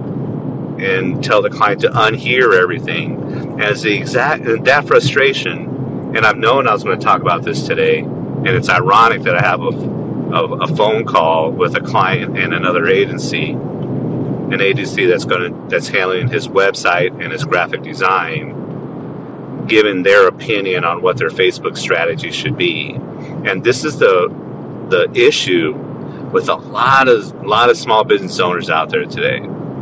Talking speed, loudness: 165 wpm, -14 LUFS